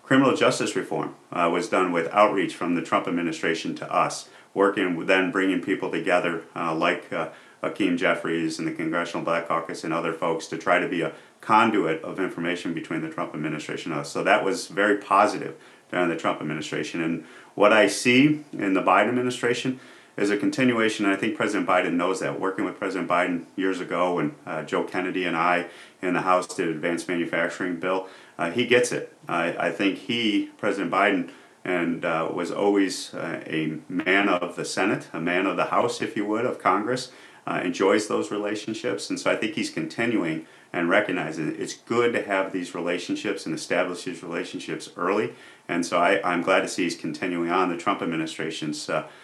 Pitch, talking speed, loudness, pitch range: 95 Hz, 195 wpm, -25 LUFS, 85-120 Hz